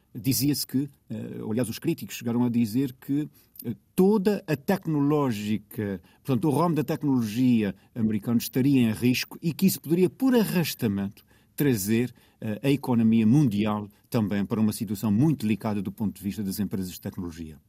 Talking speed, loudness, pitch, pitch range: 155 wpm, -26 LUFS, 120 Hz, 105-145 Hz